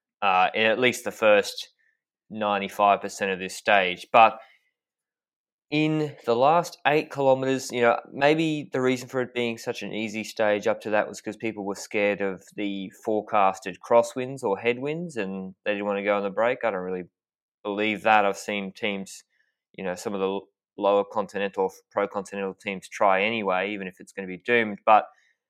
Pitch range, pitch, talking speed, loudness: 100-125 Hz, 105 Hz, 185 wpm, -25 LUFS